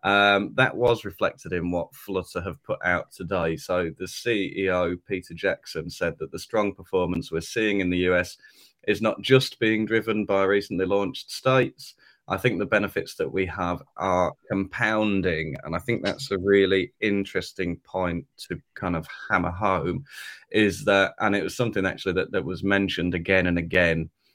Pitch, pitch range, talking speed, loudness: 95 Hz, 90-100 Hz, 180 wpm, -25 LUFS